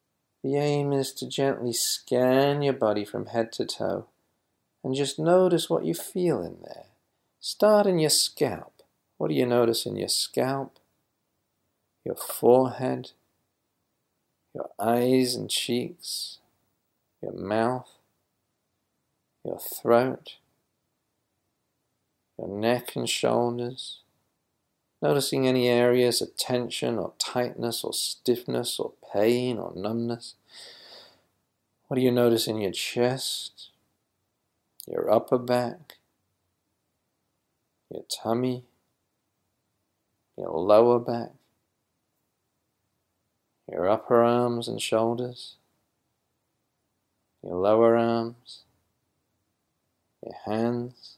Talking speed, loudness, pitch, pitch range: 95 wpm, -26 LUFS, 120 Hz, 110-125 Hz